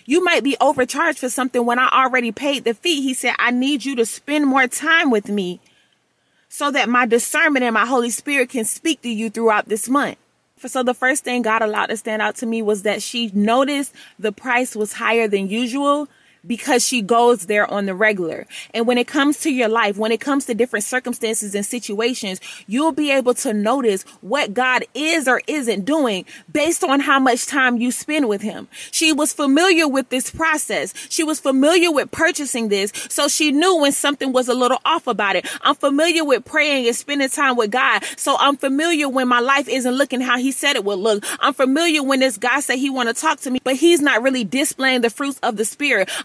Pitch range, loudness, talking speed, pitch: 230-285 Hz, -17 LUFS, 220 wpm, 255 Hz